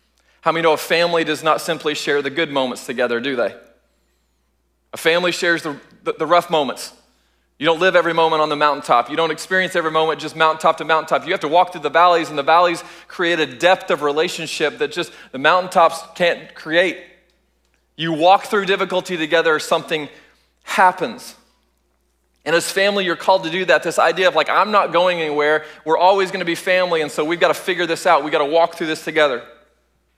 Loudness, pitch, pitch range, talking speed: -17 LUFS, 160 Hz, 150-175 Hz, 210 wpm